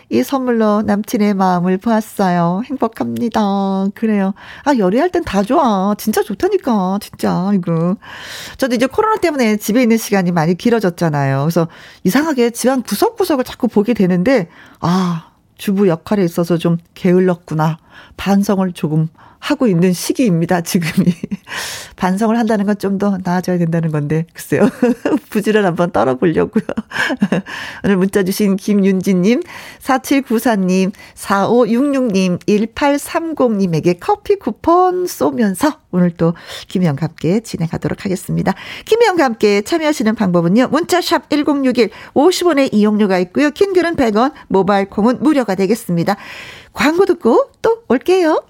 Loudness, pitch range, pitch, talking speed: -15 LUFS, 185-265 Hz, 210 Hz, 300 characters per minute